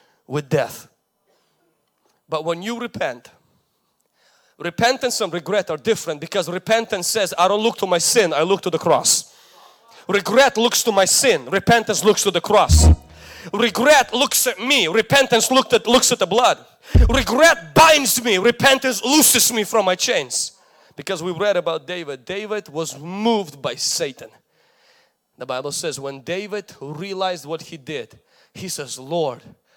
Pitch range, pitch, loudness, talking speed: 170-235 Hz, 200 Hz, -17 LUFS, 155 wpm